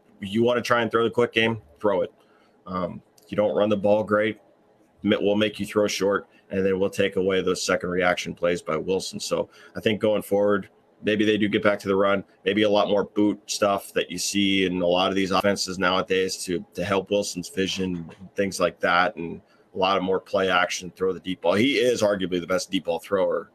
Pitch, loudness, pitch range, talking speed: 100 Hz, -24 LUFS, 95-105 Hz, 230 wpm